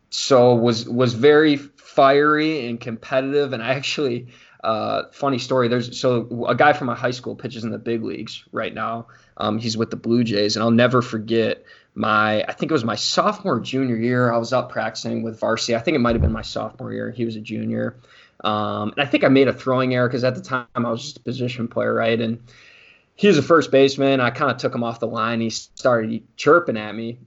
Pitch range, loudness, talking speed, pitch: 115-130 Hz, -20 LUFS, 230 wpm, 120 Hz